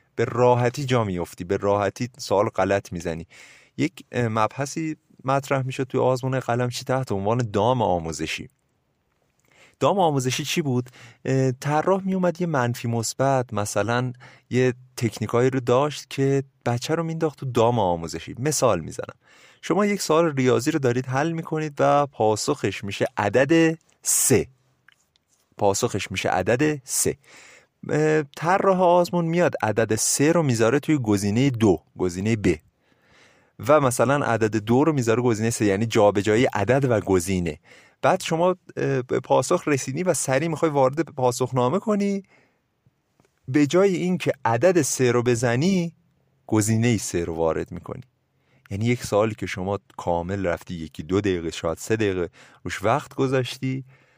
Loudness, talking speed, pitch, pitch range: -23 LUFS, 145 wpm, 125 Hz, 110-145 Hz